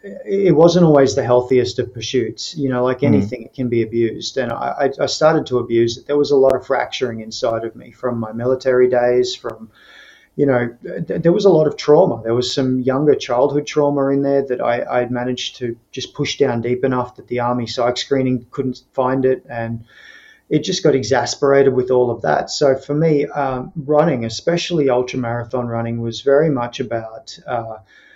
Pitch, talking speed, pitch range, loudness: 125 Hz, 200 wpm, 120-140 Hz, -17 LUFS